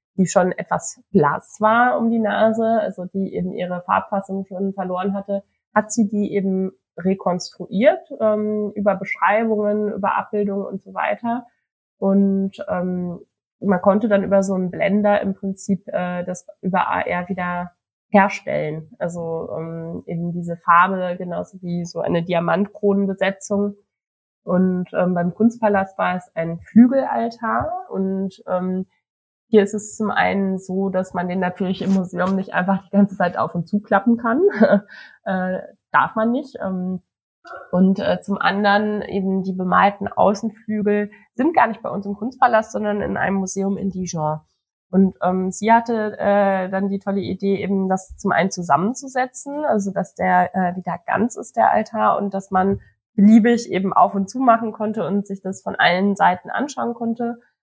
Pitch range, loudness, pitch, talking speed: 185-215 Hz, -20 LUFS, 195 Hz, 160 wpm